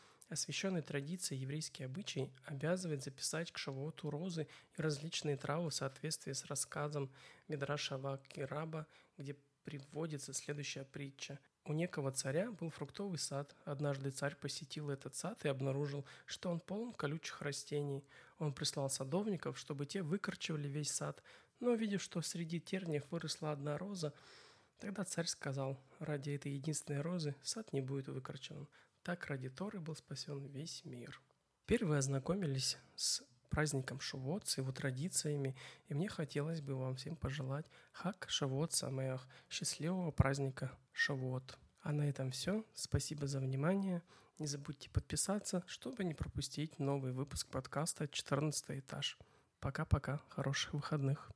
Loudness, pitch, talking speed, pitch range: -42 LUFS, 145 Hz, 135 wpm, 140-165 Hz